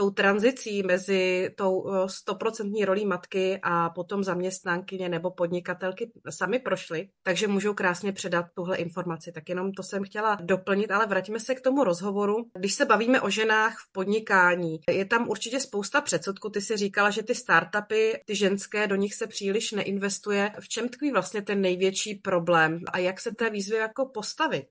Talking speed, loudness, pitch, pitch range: 170 wpm, -26 LUFS, 200 Hz, 185-215 Hz